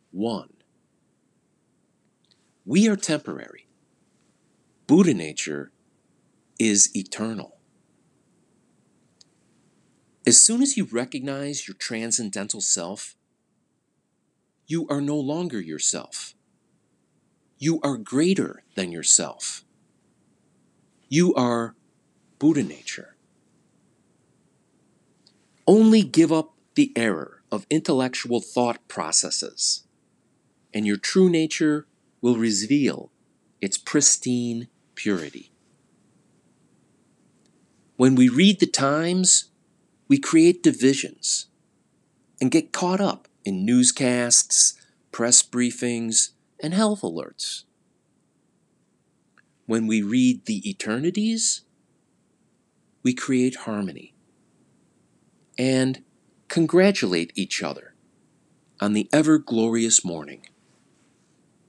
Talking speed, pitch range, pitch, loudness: 80 wpm, 120-185 Hz, 140 Hz, -21 LUFS